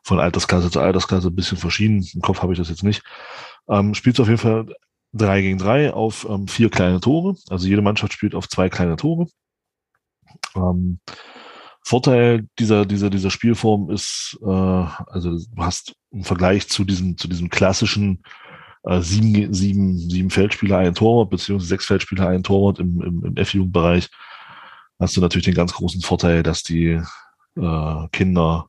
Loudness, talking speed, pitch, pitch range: -19 LUFS, 165 wpm, 95 Hz, 90-105 Hz